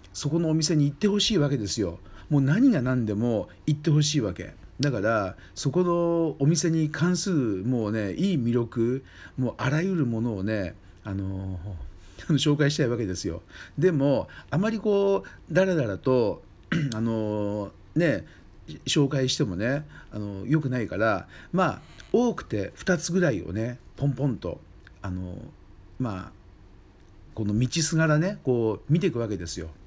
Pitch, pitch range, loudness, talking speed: 125 Hz, 100-155 Hz, -26 LUFS, 295 characters per minute